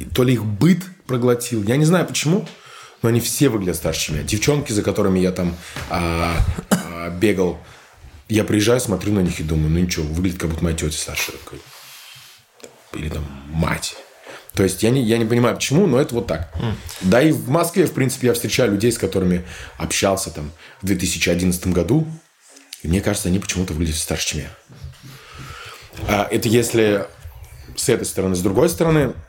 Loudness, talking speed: -19 LUFS, 175 wpm